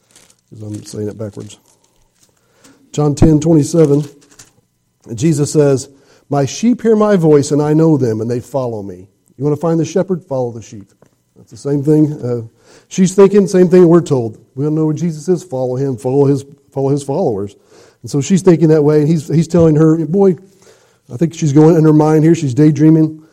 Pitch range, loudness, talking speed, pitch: 130-160 Hz, -13 LUFS, 205 wpm, 150 Hz